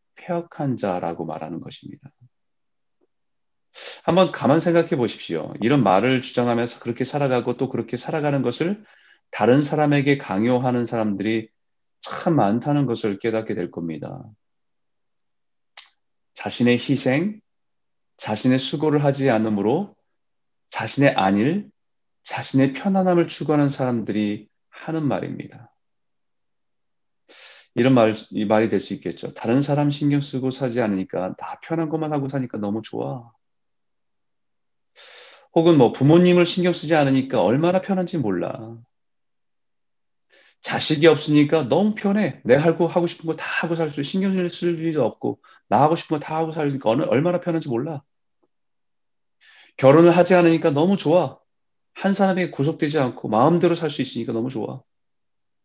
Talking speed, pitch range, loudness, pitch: 290 characters per minute, 115-165 Hz, -21 LUFS, 140 Hz